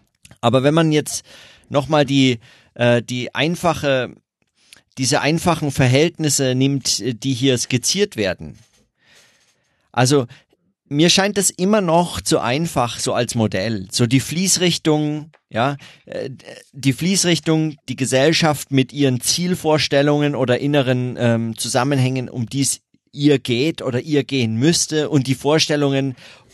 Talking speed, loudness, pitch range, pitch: 120 wpm, -18 LUFS, 125-155 Hz, 140 Hz